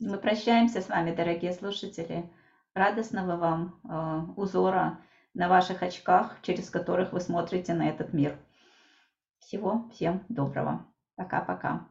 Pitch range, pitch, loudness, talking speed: 170-200 Hz, 185 Hz, -29 LUFS, 120 wpm